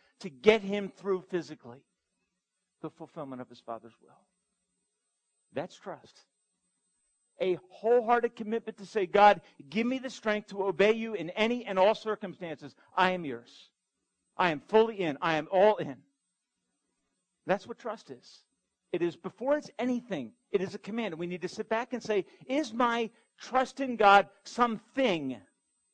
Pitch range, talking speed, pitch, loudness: 175-230 Hz, 160 wpm, 200 Hz, -29 LUFS